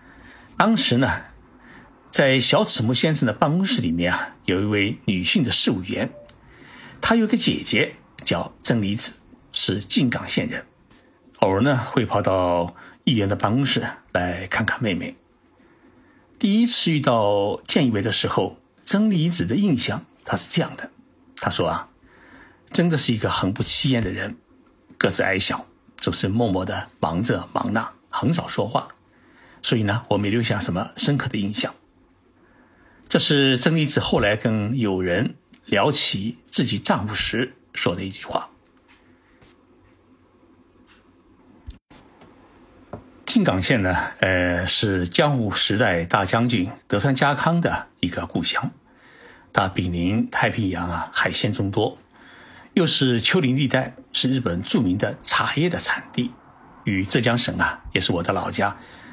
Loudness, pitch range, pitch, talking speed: -20 LUFS, 100-140 Hz, 120 Hz, 210 characters per minute